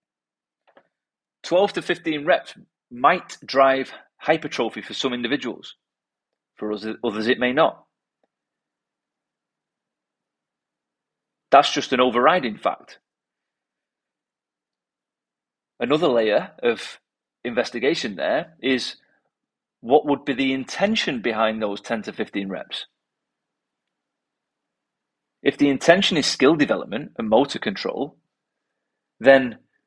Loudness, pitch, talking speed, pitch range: -21 LUFS, 130 Hz, 95 wpm, 110-140 Hz